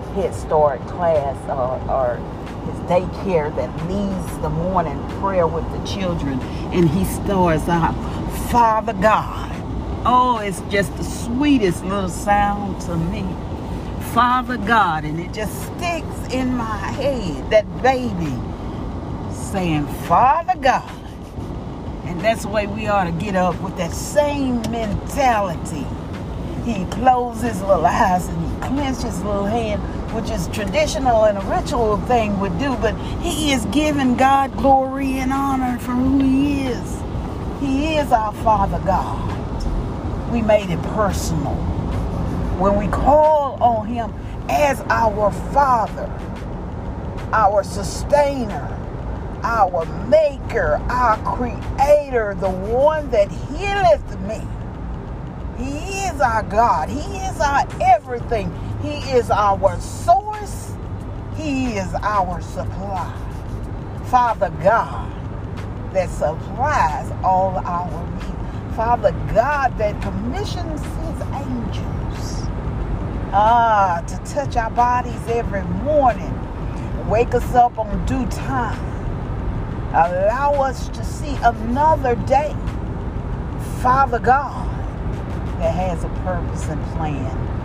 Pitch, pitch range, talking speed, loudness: 240 Hz, 180-275 Hz, 120 wpm, -20 LUFS